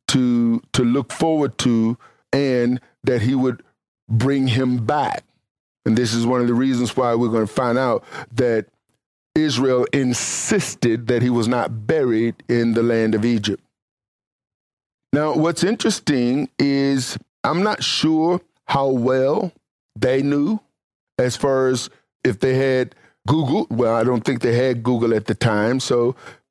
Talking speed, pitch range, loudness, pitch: 150 wpm, 115-135 Hz, -20 LUFS, 125 Hz